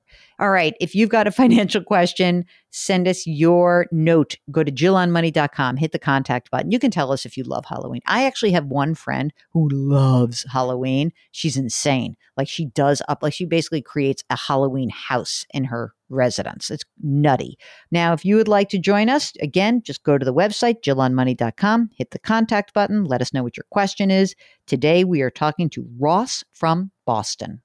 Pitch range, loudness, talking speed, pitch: 135-195 Hz, -20 LUFS, 190 wpm, 160 Hz